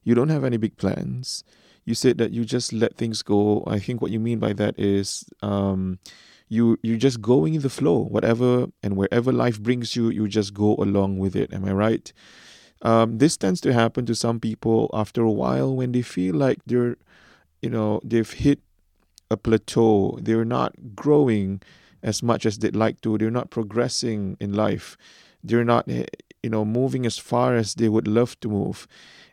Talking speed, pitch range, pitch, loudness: 190 wpm, 105-120 Hz, 115 Hz, -23 LUFS